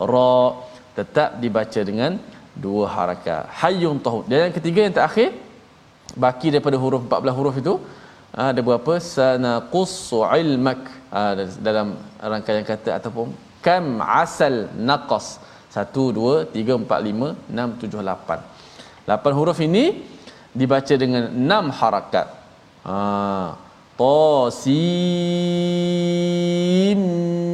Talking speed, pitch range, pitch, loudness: 105 wpm, 110-170 Hz, 130 Hz, -20 LUFS